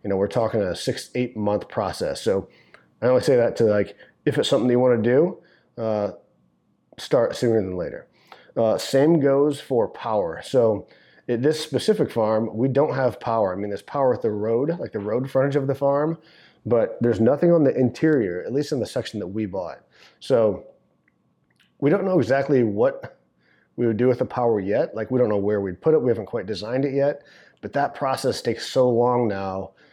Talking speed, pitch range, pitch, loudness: 210 wpm, 110-140 Hz, 125 Hz, -22 LUFS